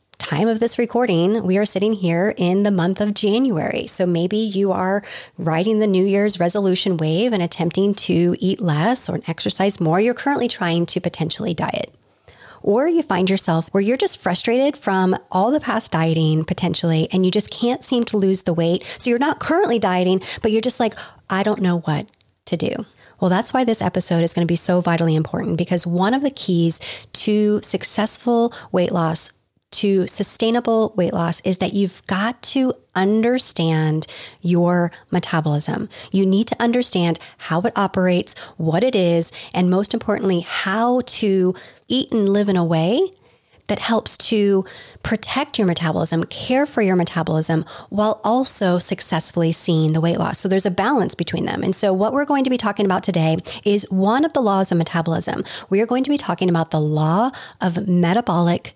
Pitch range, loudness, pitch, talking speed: 170-220 Hz, -19 LUFS, 190 Hz, 185 wpm